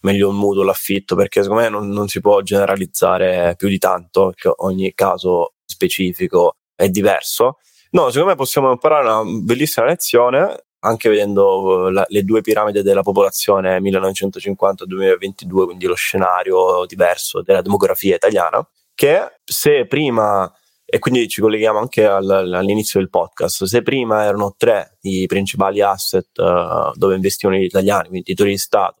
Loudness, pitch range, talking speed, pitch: -16 LUFS, 95-115 Hz, 150 wpm, 100 Hz